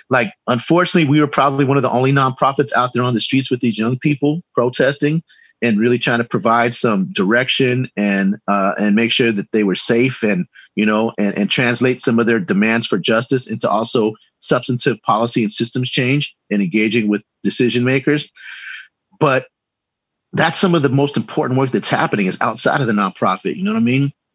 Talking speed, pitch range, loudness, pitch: 195 wpm, 115-140 Hz, -16 LUFS, 125 Hz